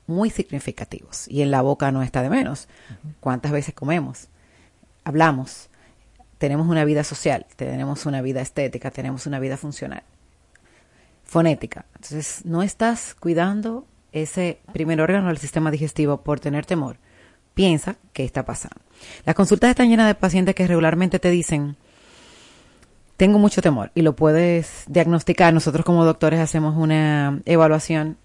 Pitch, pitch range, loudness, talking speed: 155 Hz, 140-175 Hz, -20 LUFS, 140 wpm